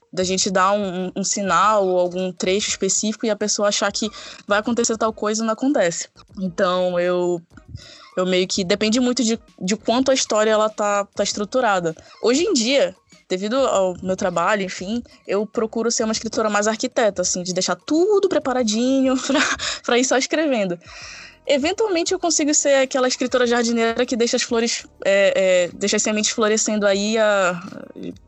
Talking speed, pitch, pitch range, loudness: 170 wpm, 215 Hz, 190-250 Hz, -20 LUFS